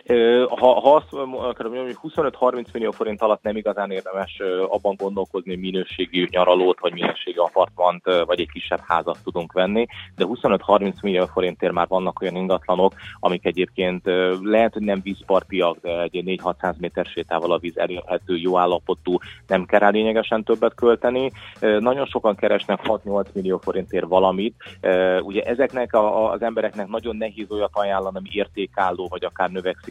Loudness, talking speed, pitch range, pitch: -21 LUFS, 150 wpm, 90-110 Hz, 95 Hz